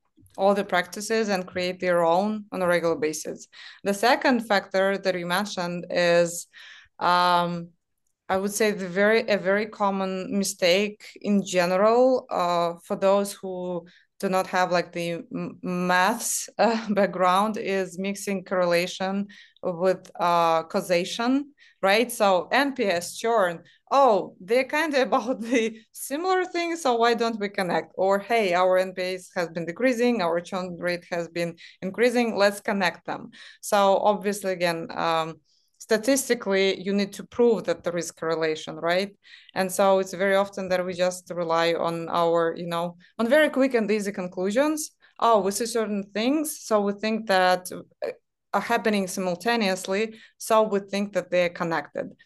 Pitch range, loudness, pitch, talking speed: 180-220 Hz, -24 LUFS, 195 Hz, 155 wpm